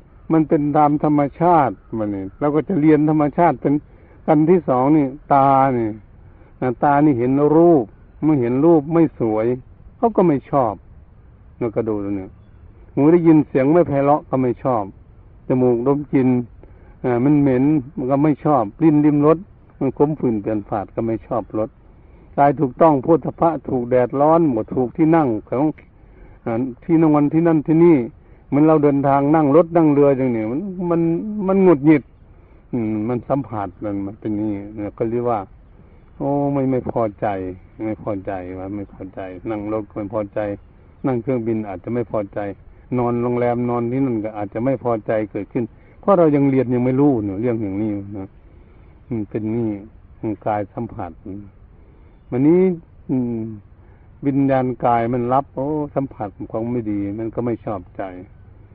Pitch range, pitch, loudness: 105-145 Hz, 120 Hz, -18 LUFS